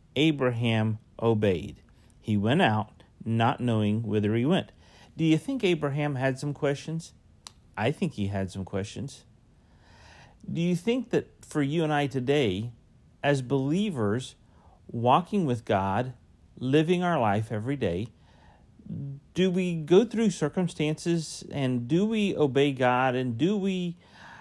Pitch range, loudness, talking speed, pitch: 110-160 Hz, -27 LUFS, 135 wpm, 130 Hz